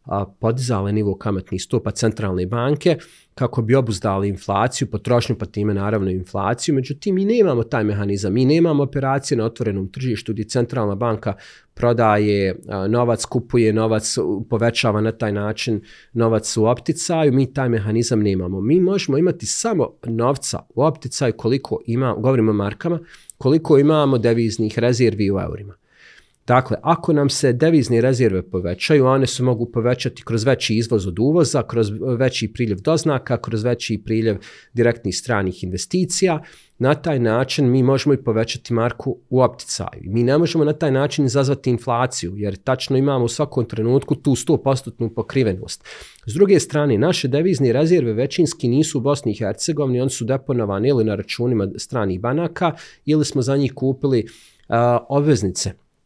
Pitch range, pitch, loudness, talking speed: 110-140 Hz, 120 Hz, -19 LUFS, 155 wpm